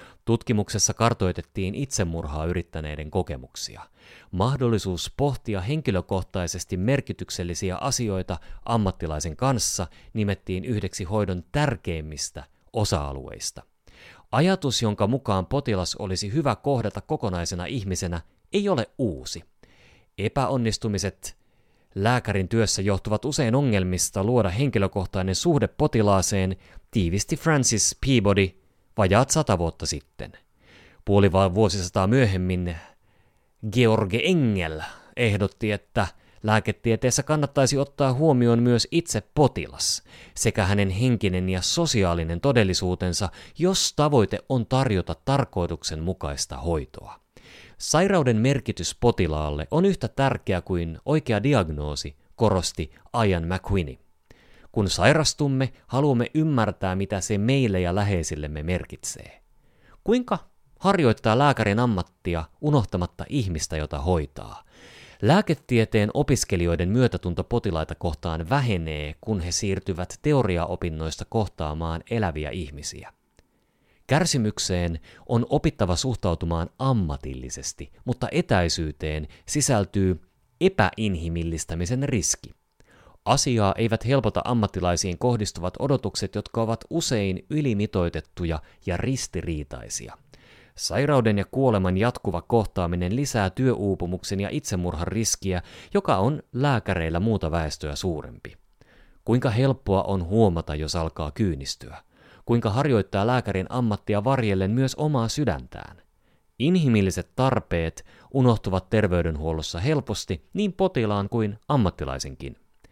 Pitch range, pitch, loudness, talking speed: 90-125 Hz, 100 Hz, -24 LUFS, 95 wpm